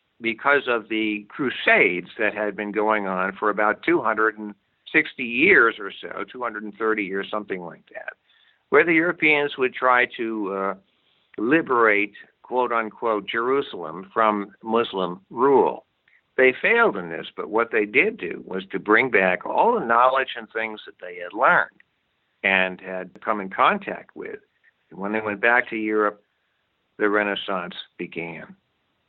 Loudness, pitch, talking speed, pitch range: -21 LUFS, 105 Hz, 150 wpm, 100-120 Hz